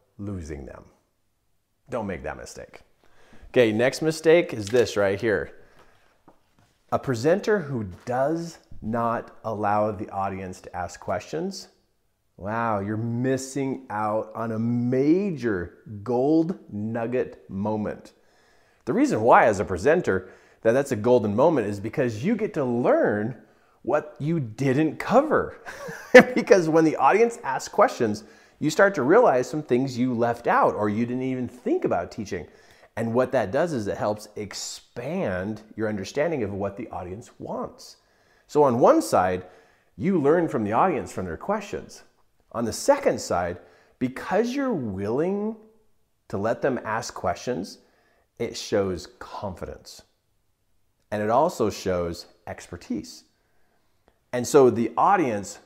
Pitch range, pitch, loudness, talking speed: 105-145 Hz, 120 Hz, -24 LUFS, 140 wpm